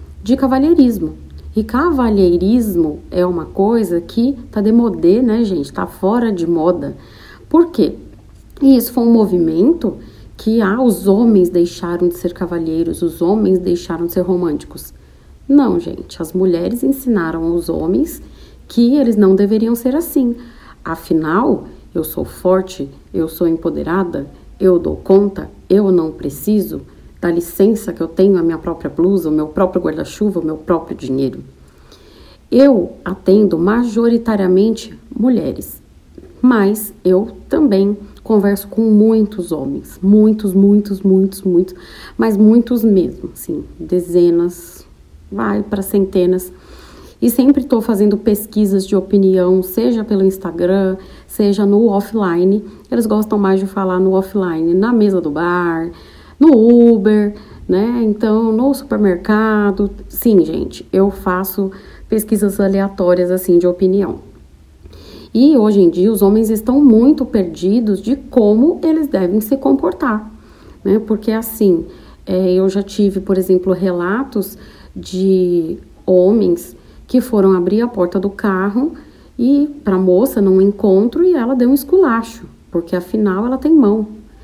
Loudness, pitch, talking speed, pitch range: -14 LUFS, 195 Hz, 135 wpm, 180-225 Hz